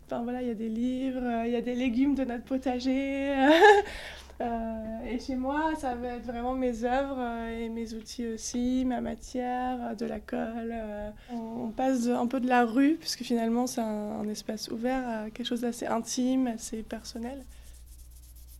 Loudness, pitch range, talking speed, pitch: -29 LUFS, 230-255 Hz, 170 wpm, 240 Hz